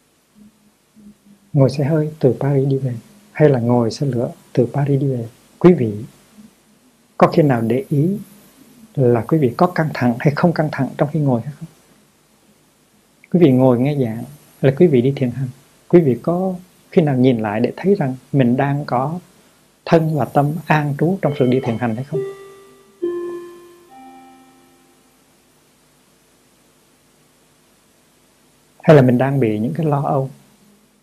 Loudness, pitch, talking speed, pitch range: -17 LUFS, 150 Hz, 160 wpm, 130-195 Hz